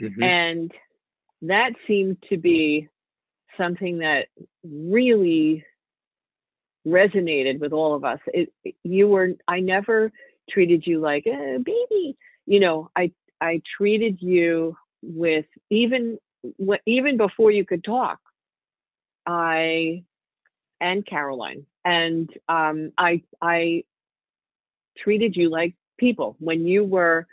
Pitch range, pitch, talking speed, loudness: 165-210 Hz, 175 Hz, 110 wpm, -22 LUFS